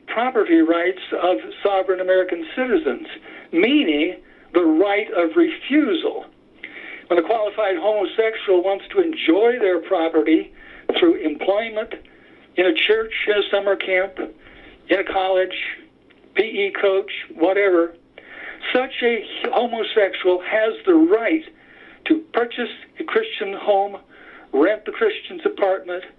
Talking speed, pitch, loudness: 115 wpm, 310 Hz, -20 LUFS